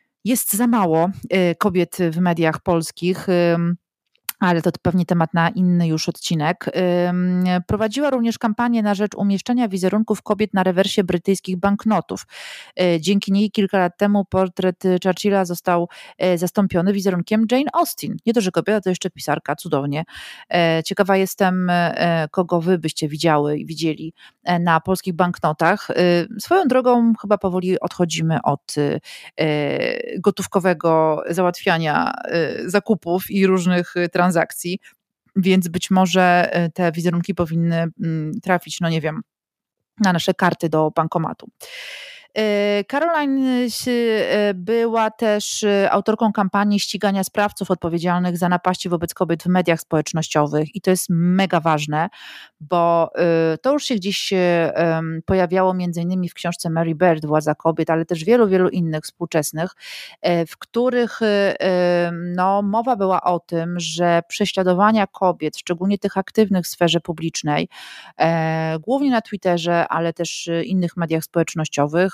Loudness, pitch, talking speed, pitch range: -19 LUFS, 180 Hz, 125 wpm, 170-205 Hz